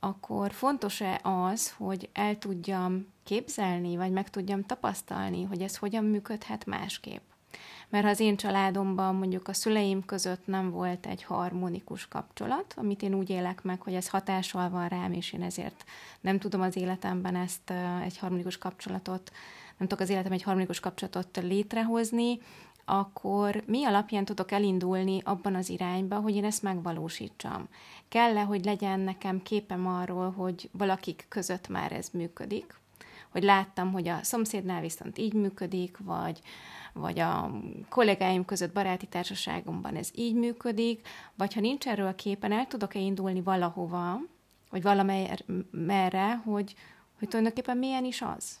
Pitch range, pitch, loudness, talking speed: 185-205 Hz, 195 Hz, -31 LUFS, 150 wpm